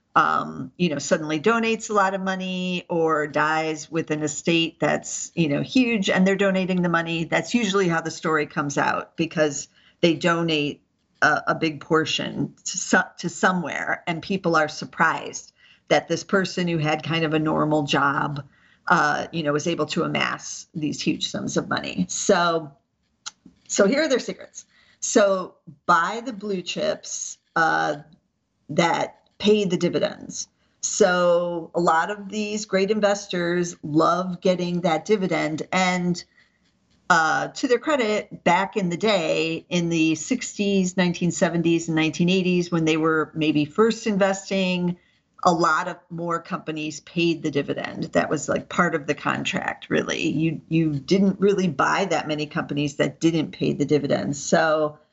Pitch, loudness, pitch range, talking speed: 170 Hz, -23 LUFS, 155-190 Hz, 155 wpm